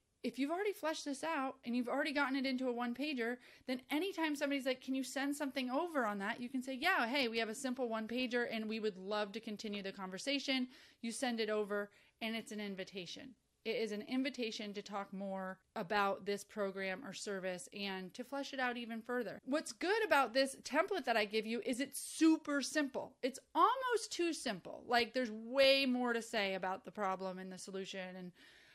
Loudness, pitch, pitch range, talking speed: -38 LUFS, 245 Hz, 210-275 Hz, 210 wpm